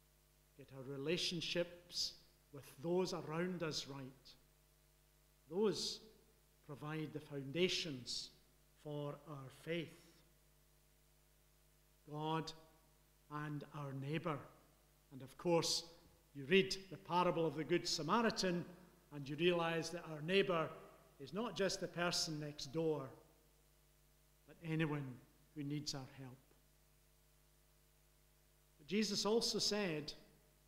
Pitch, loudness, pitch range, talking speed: 155 Hz, -41 LUFS, 150-170 Hz, 105 wpm